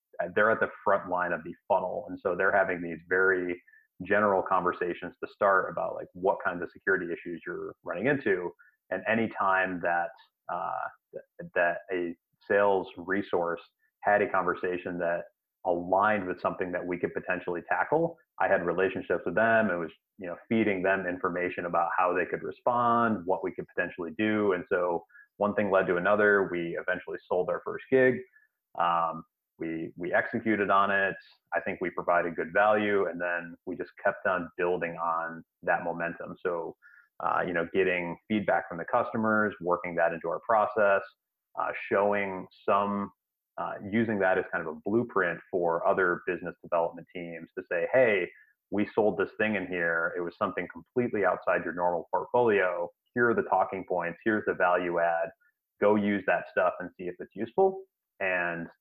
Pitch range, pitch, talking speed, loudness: 85-110 Hz, 95 Hz, 175 wpm, -29 LUFS